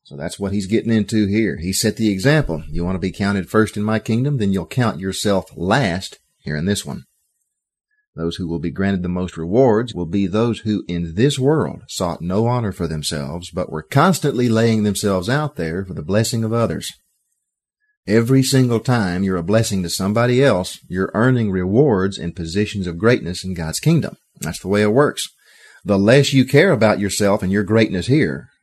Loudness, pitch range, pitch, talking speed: -18 LUFS, 95-120 Hz, 105 Hz, 200 wpm